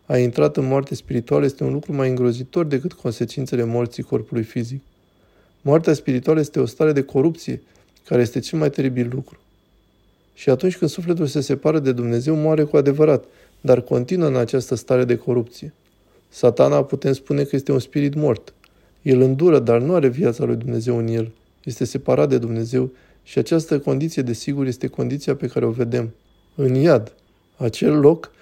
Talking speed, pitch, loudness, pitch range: 175 wpm, 130 Hz, -20 LUFS, 120-145 Hz